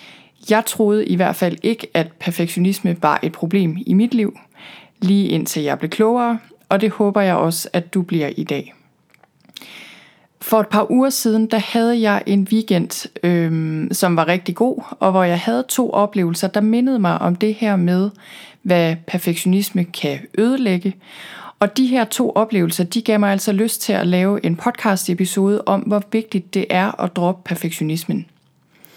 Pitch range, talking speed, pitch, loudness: 180-220 Hz, 175 wpm, 195 Hz, -18 LUFS